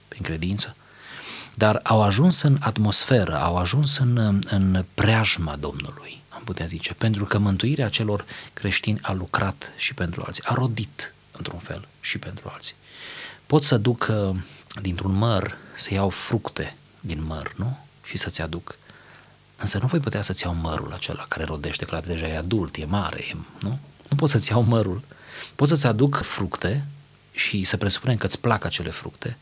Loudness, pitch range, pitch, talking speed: -22 LUFS, 90-125 Hz, 105 Hz, 170 wpm